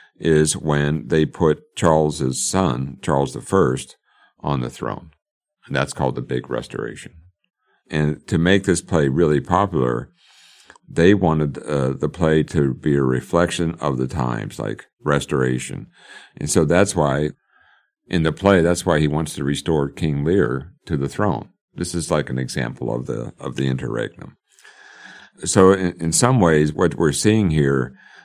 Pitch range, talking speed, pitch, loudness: 70-85 Hz, 160 wpm, 75 Hz, -20 LUFS